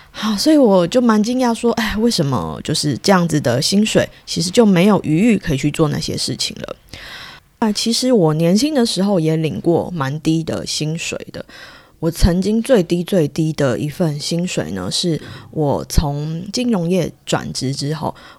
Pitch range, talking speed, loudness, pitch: 155-215 Hz, 255 characters per minute, -17 LUFS, 175 Hz